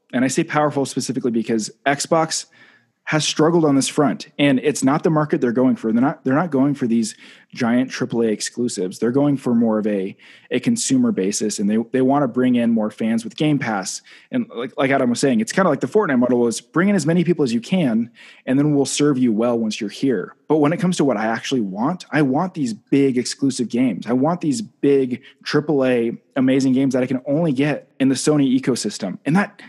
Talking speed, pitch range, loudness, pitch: 230 wpm, 120-155 Hz, -19 LUFS, 135 Hz